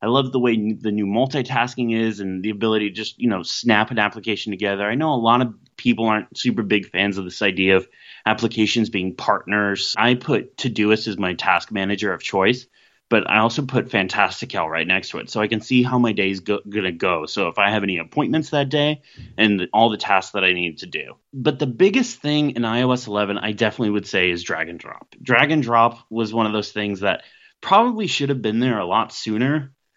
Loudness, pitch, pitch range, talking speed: -20 LUFS, 110 Hz, 105-125 Hz, 225 wpm